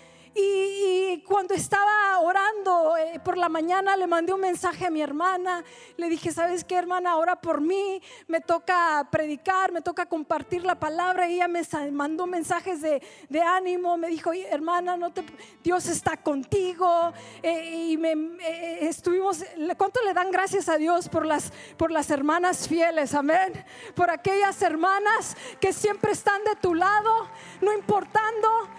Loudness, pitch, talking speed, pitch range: -25 LUFS, 355 Hz, 160 wpm, 330-385 Hz